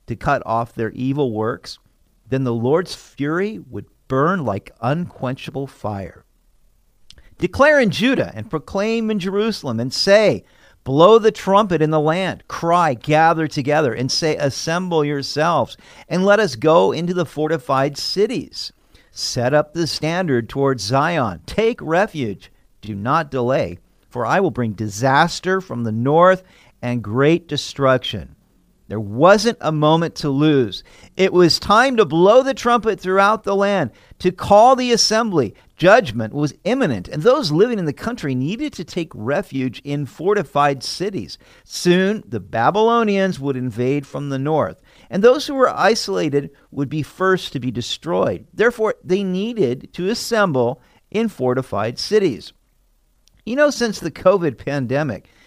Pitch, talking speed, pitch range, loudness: 155 Hz, 145 wpm, 130-195 Hz, -18 LUFS